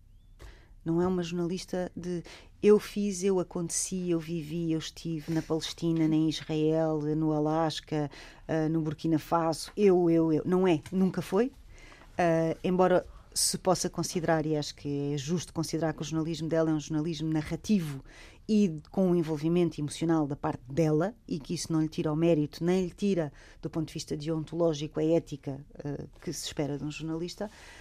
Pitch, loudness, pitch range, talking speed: 160 Hz, -30 LUFS, 155-175 Hz, 180 wpm